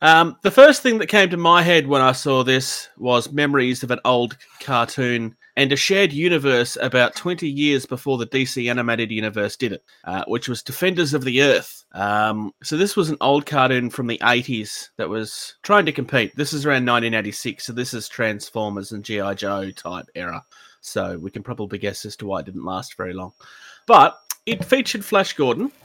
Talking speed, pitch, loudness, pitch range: 200 wpm, 125 Hz, -19 LUFS, 110-150 Hz